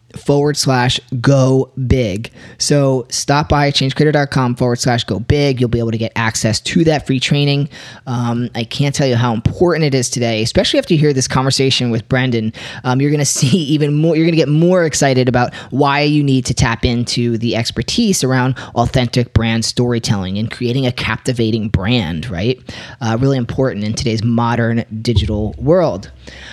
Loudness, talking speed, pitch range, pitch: -15 LUFS, 180 wpm, 115-140 Hz, 125 Hz